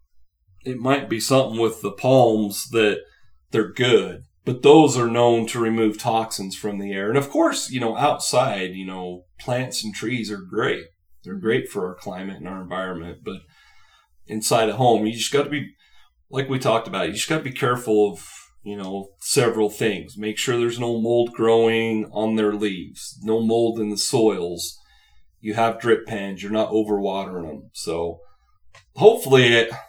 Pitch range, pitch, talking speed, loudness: 95-120 Hz, 110 Hz, 180 wpm, -21 LUFS